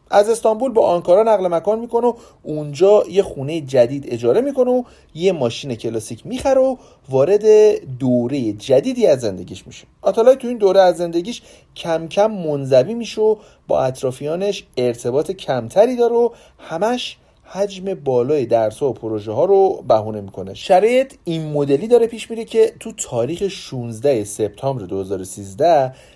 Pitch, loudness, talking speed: 170 Hz, -17 LUFS, 150 wpm